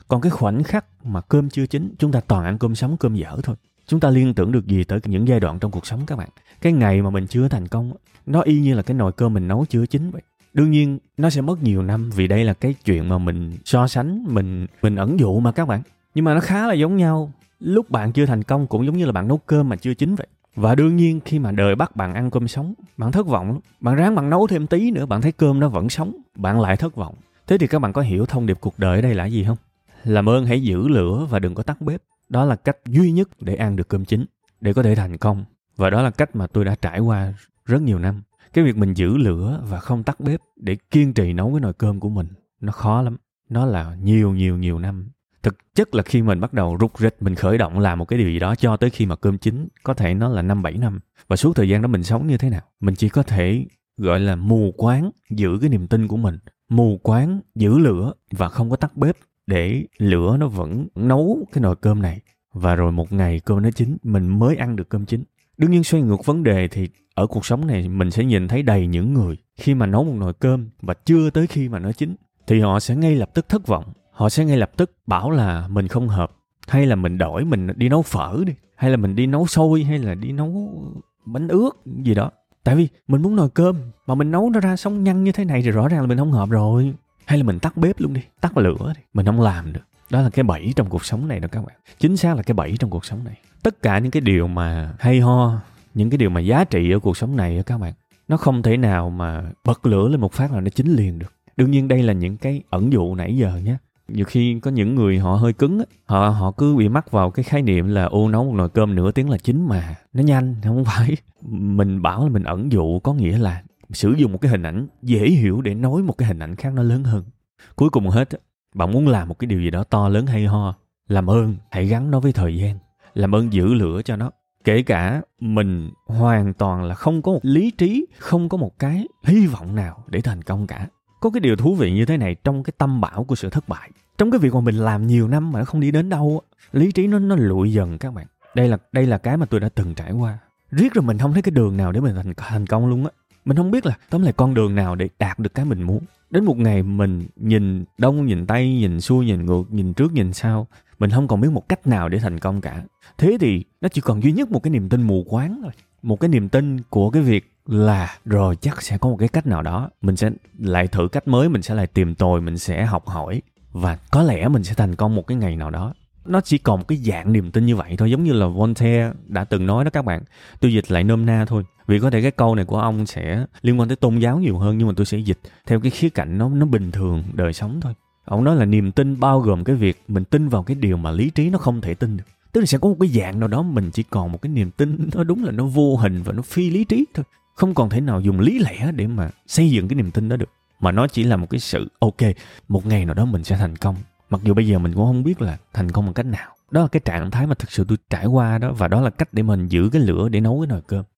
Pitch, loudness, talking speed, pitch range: 115 Hz, -19 LUFS, 275 wpm, 100-140 Hz